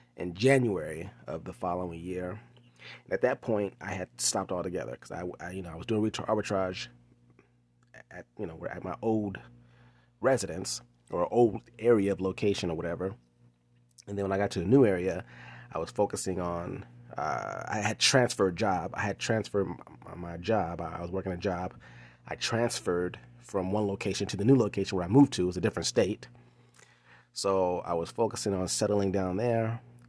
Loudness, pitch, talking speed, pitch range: -30 LUFS, 95 Hz, 190 wpm, 85-110 Hz